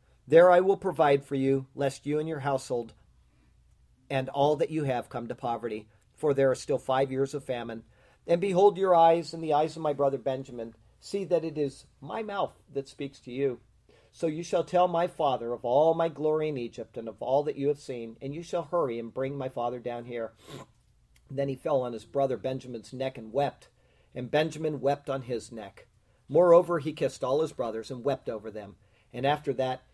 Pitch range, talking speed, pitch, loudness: 120-155 Hz, 215 wpm, 135 Hz, -28 LUFS